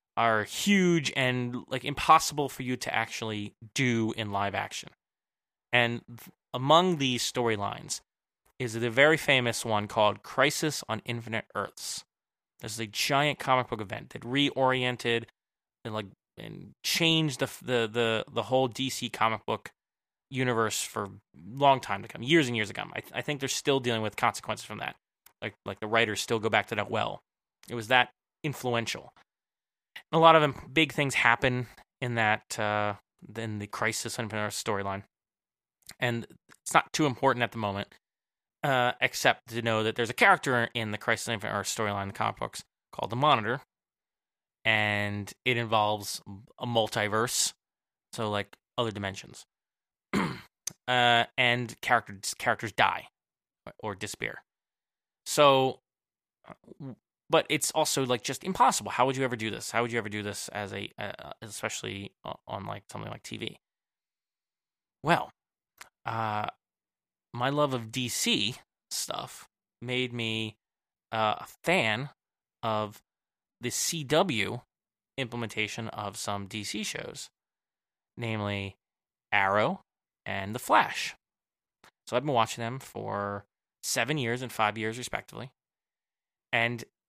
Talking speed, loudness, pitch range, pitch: 145 wpm, -29 LUFS, 110-130 Hz, 115 Hz